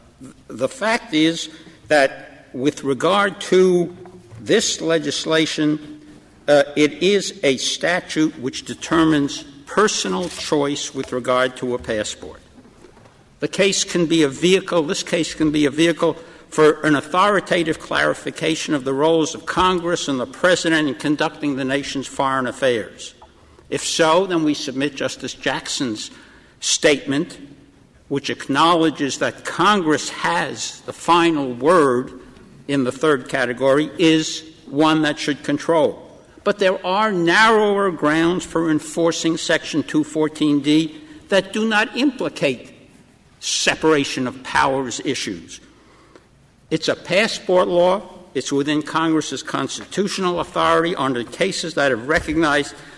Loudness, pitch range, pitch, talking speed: -19 LUFS, 145-175 Hz, 155 Hz, 125 wpm